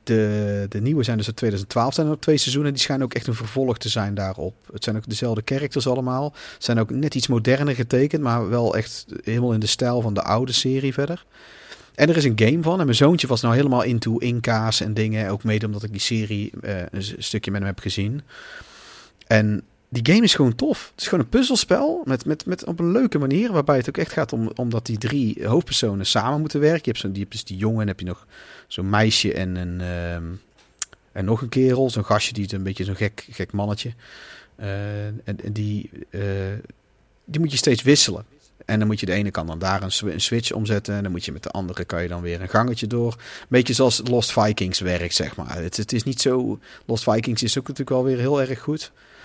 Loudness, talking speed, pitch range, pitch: -22 LUFS, 240 wpm, 105-130 Hz, 115 Hz